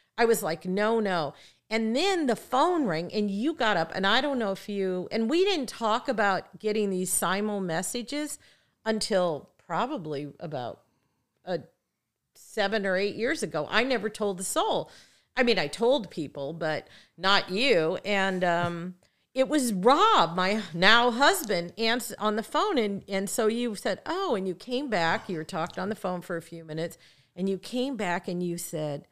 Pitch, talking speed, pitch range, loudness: 200 Hz, 185 wpm, 175-230 Hz, -27 LUFS